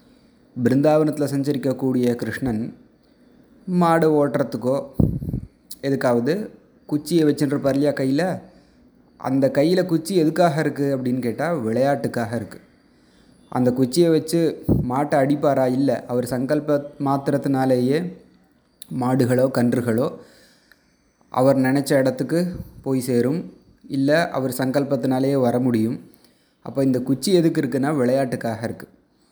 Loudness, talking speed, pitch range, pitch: -21 LUFS, 95 wpm, 125-150 Hz, 140 Hz